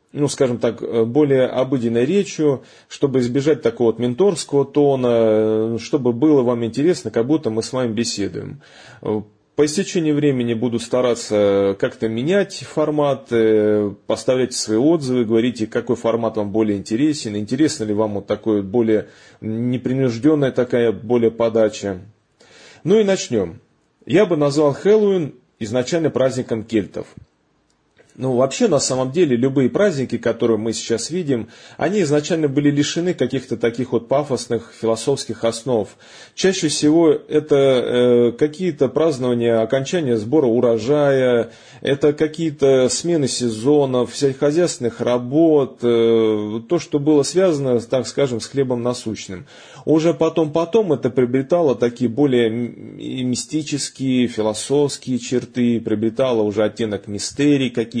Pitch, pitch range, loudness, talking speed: 125 Hz, 115-145 Hz, -18 LUFS, 125 wpm